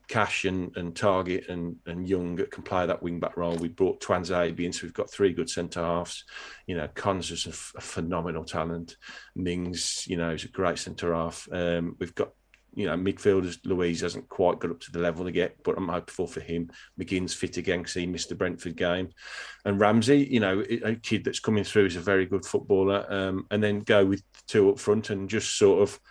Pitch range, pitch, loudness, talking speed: 85-100 Hz, 90 Hz, -28 LUFS, 215 wpm